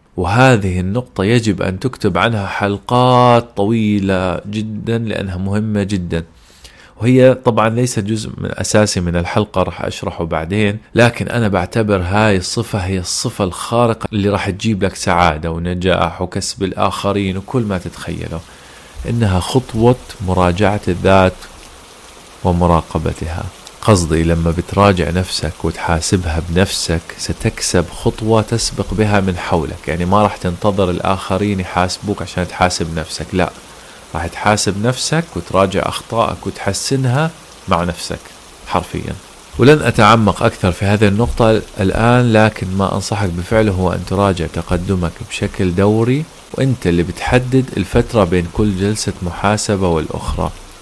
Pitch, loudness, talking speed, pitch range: 100 Hz, -16 LUFS, 125 wpm, 90-110 Hz